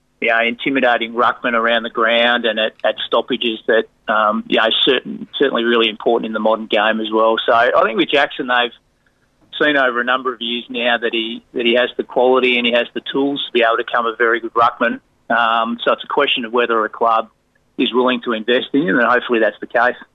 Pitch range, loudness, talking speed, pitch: 115-125 Hz, -16 LUFS, 240 wpm, 120 Hz